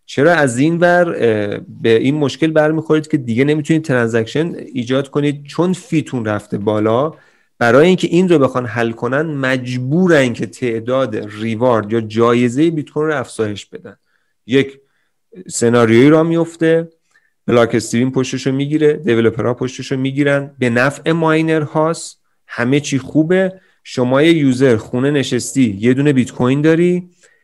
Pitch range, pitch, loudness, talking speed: 120-155 Hz, 135 Hz, -15 LUFS, 140 wpm